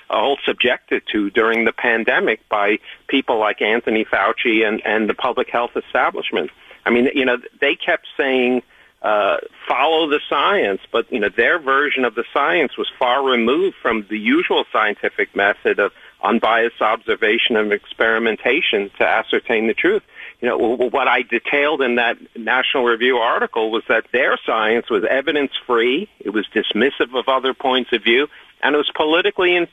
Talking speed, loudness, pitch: 170 wpm, -18 LUFS, 175 Hz